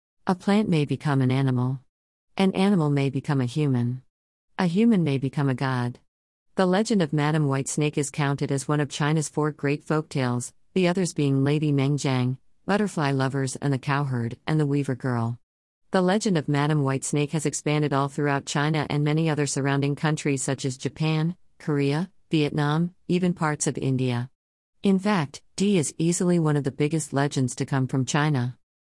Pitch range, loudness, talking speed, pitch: 135-155 Hz, -25 LUFS, 180 wpm, 145 Hz